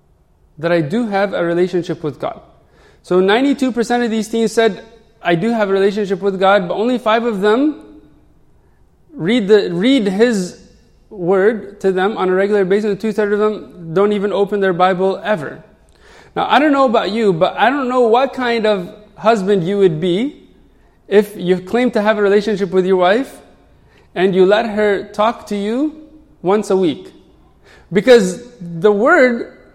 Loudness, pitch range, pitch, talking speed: -15 LUFS, 190-230 Hz, 205 Hz, 175 wpm